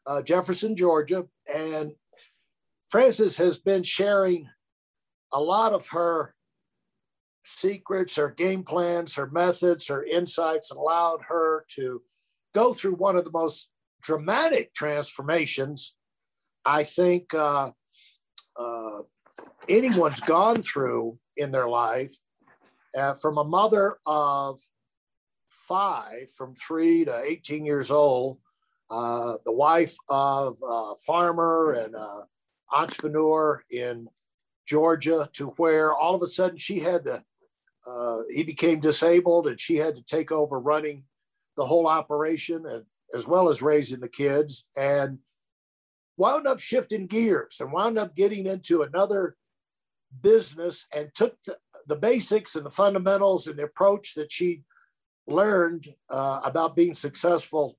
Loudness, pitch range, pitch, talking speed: -25 LUFS, 140-180 Hz, 160 Hz, 130 wpm